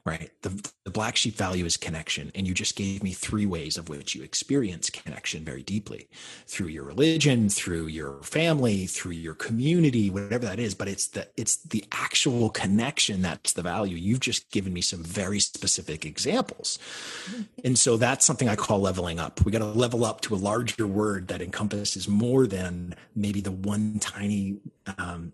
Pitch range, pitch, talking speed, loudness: 90-115 Hz, 100 Hz, 185 wpm, -27 LUFS